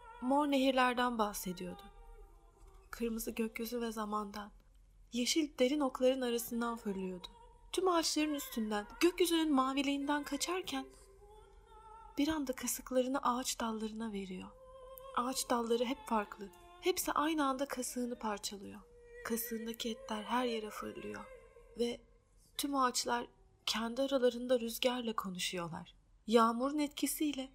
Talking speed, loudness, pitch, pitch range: 100 wpm, -36 LUFS, 255 Hz, 230-295 Hz